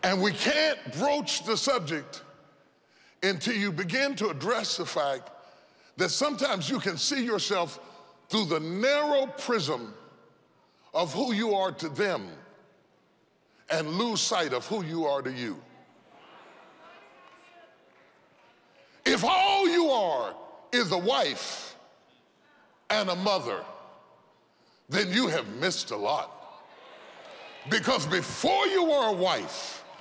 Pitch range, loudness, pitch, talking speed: 185-280 Hz, -28 LUFS, 215 Hz, 120 wpm